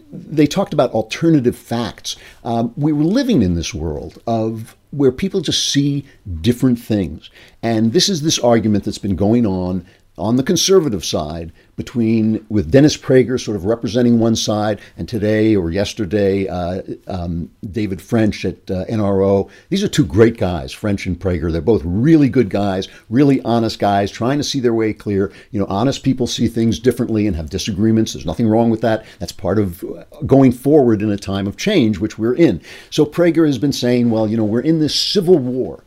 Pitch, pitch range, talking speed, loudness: 110 Hz, 100-130 Hz, 190 wpm, -17 LUFS